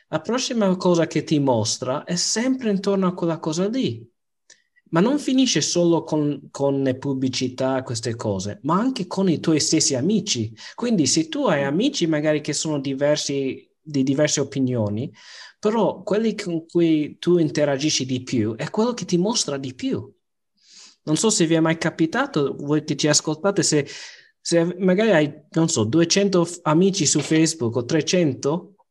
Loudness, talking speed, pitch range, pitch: -21 LUFS, 170 wpm, 140-190 Hz, 160 Hz